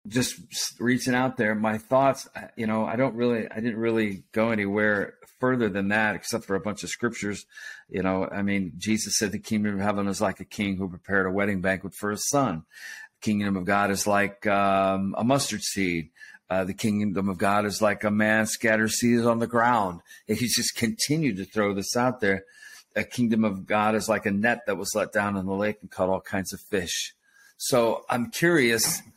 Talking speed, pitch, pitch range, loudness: 215 wpm, 105 Hz, 100-115 Hz, -25 LUFS